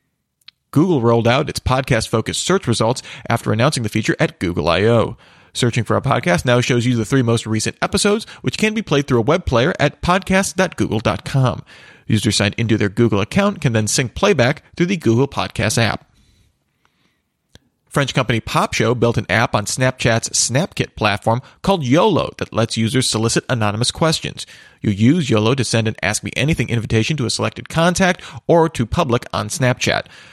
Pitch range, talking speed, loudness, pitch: 110-145 Hz, 180 wpm, -17 LUFS, 120 Hz